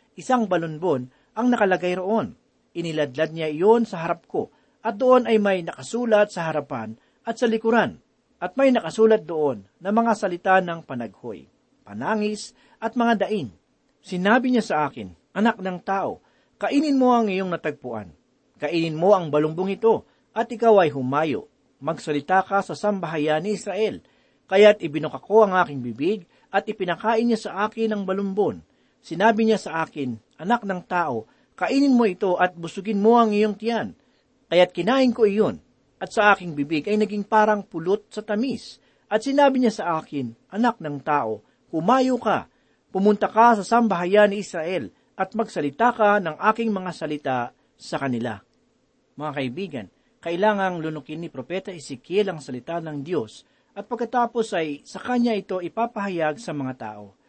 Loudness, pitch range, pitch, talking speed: -23 LUFS, 160-225 Hz, 195 Hz, 155 wpm